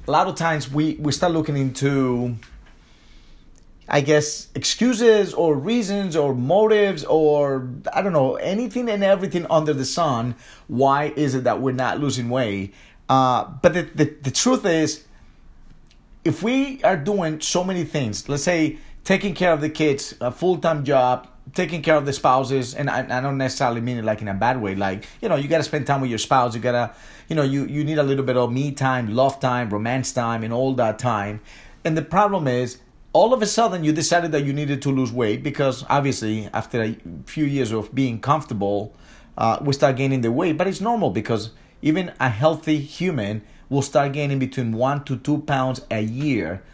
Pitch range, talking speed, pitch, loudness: 125-160 Hz, 200 wpm, 140 Hz, -21 LUFS